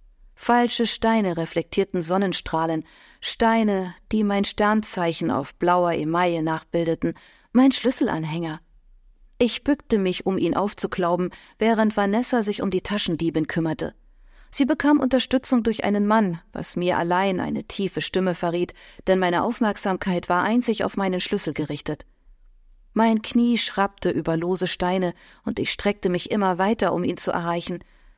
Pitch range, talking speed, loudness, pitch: 175-225 Hz, 140 wpm, -23 LUFS, 190 Hz